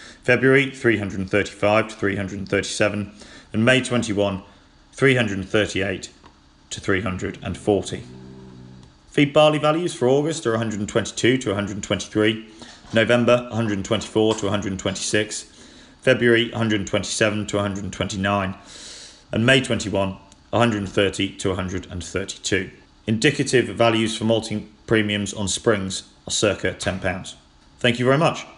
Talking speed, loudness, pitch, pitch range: 100 wpm, -21 LUFS, 105 Hz, 95-115 Hz